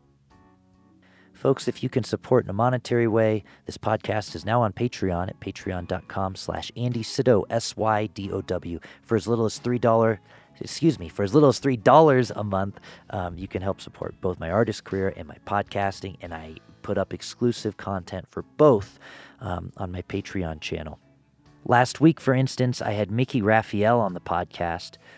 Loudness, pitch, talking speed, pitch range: -25 LUFS, 105 Hz, 165 wpm, 95-120 Hz